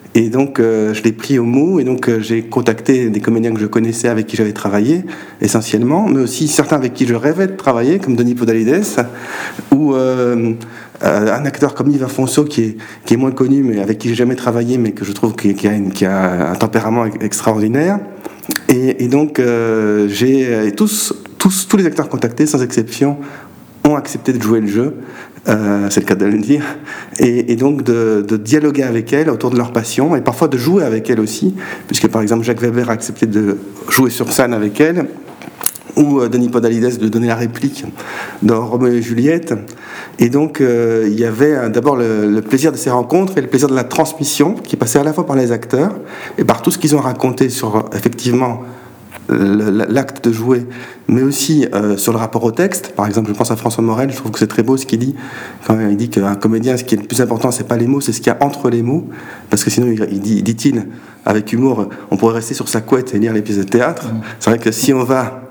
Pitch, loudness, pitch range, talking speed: 120 Hz, -14 LUFS, 110-135 Hz, 230 wpm